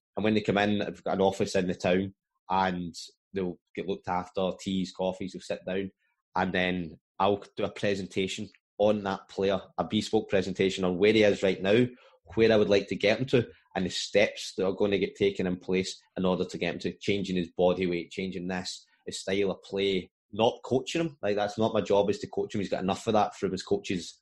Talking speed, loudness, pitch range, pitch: 235 wpm, -29 LUFS, 90-100 Hz, 95 Hz